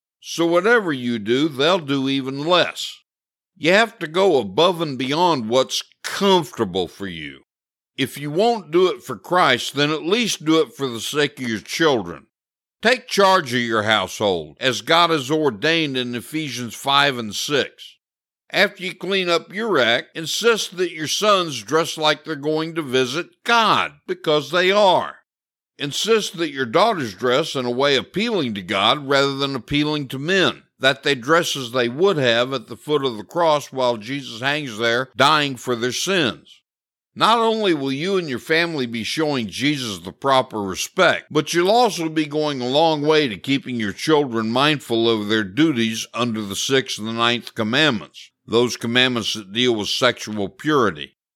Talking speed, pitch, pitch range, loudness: 175 wpm, 145 Hz, 125-170 Hz, -19 LUFS